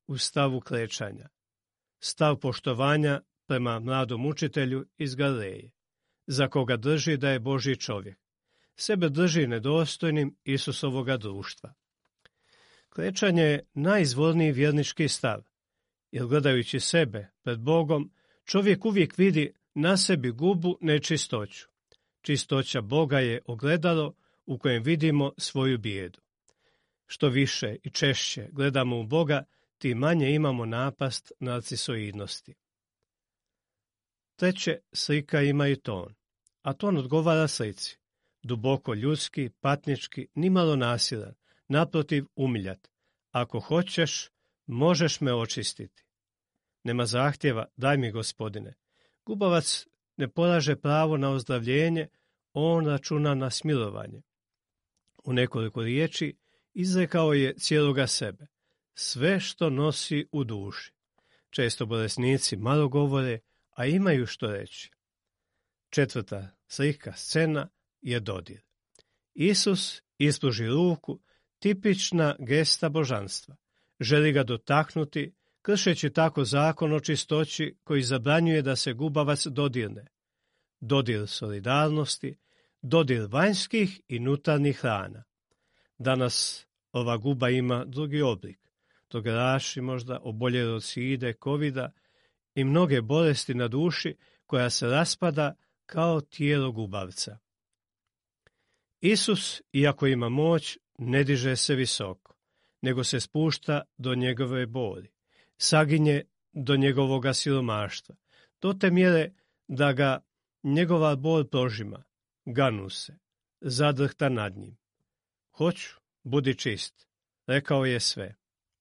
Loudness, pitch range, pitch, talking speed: -27 LUFS, 120-155 Hz, 140 Hz, 105 wpm